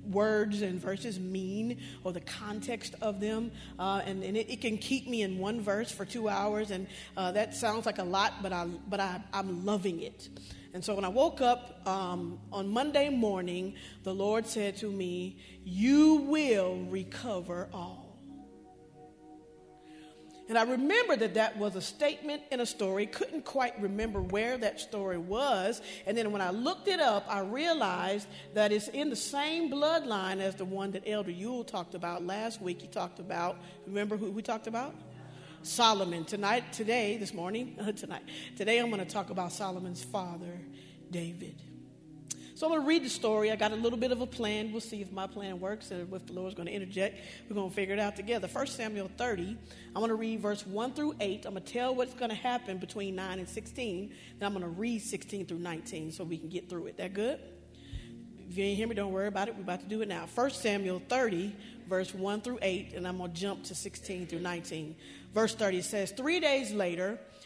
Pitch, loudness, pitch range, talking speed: 200 Hz, -33 LUFS, 185-225 Hz, 205 wpm